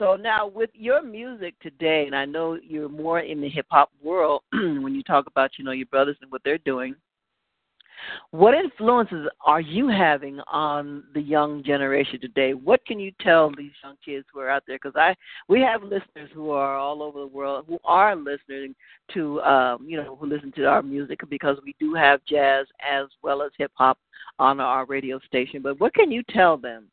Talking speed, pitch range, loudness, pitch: 205 wpm, 140-170 Hz, -23 LUFS, 145 Hz